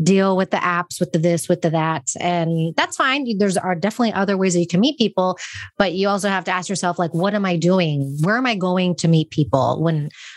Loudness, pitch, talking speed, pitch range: -19 LUFS, 185 Hz, 250 wpm, 170-200 Hz